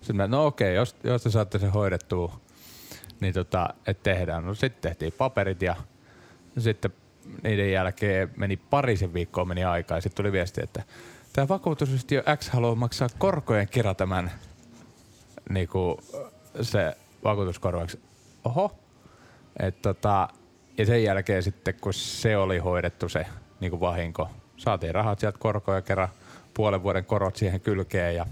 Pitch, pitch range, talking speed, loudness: 100 Hz, 90-115 Hz, 145 wpm, -27 LUFS